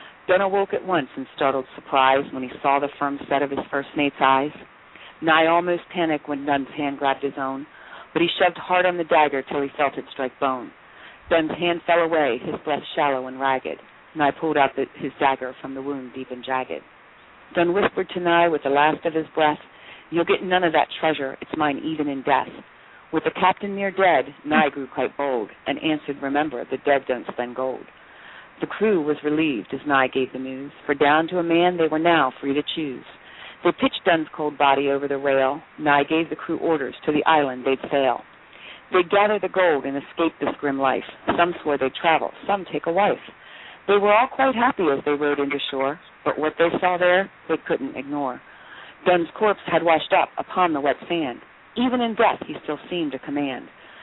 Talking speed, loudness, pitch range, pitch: 210 wpm, -22 LUFS, 140-170 Hz, 150 Hz